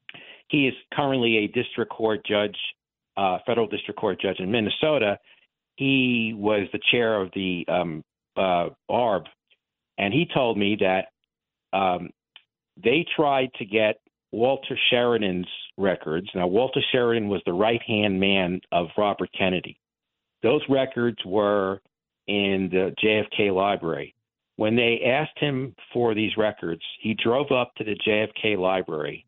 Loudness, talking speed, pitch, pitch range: -24 LUFS, 140 wpm, 110 Hz, 95-120 Hz